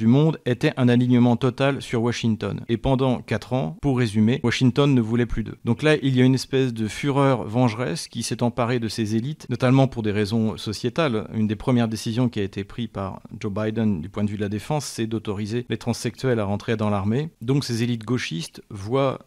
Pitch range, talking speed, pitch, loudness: 110-130 Hz, 225 wpm, 120 Hz, -23 LUFS